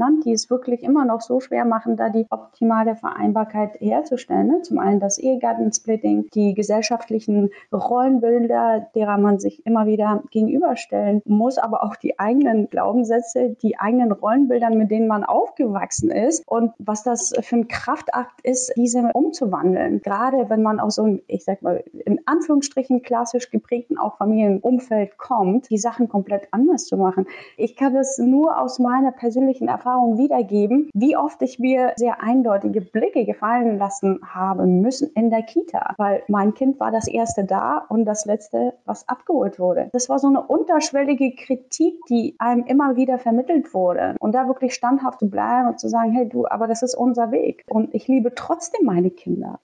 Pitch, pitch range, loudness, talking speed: 235 Hz, 215-255 Hz, -20 LUFS, 170 wpm